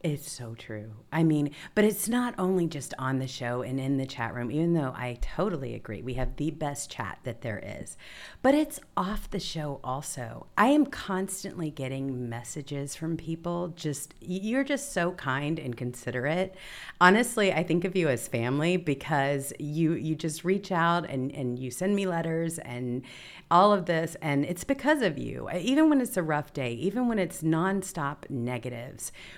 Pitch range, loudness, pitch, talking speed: 130-185 Hz, -29 LUFS, 160 Hz, 185 wpm